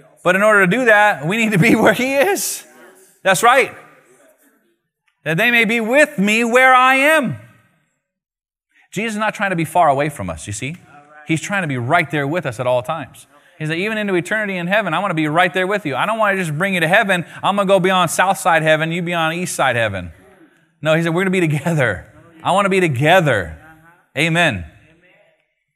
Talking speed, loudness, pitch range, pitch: 230 wpm, -16 LUFS, 155-200 Hz, 175 Hz